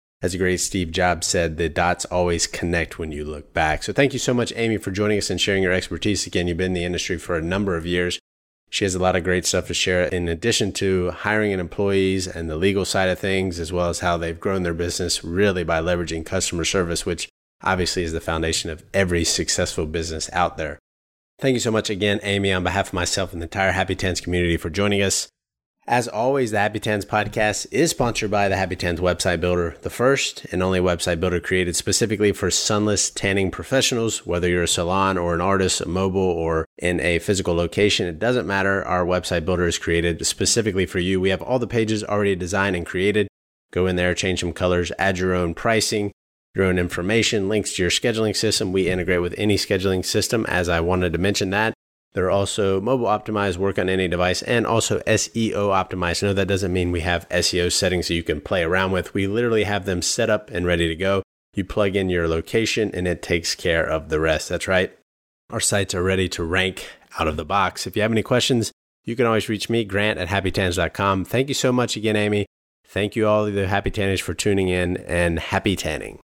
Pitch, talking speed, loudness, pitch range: 95 Hz, 225 wpm, -21 LUFS, 90-105 Hz